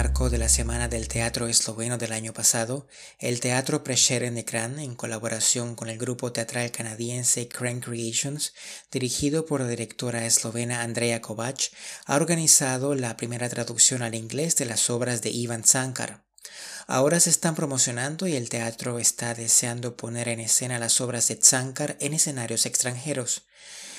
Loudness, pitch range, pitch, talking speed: -24 LUFS, 115-130 Hz, 120 Hz, 160 wpm